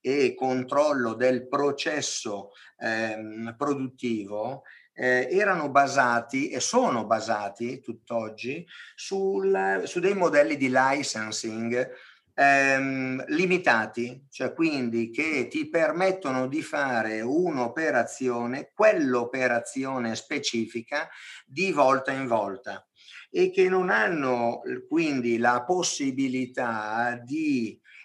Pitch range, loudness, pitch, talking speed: 120-155 Hz, -26 LUFS, 130 Hz, 90 wpm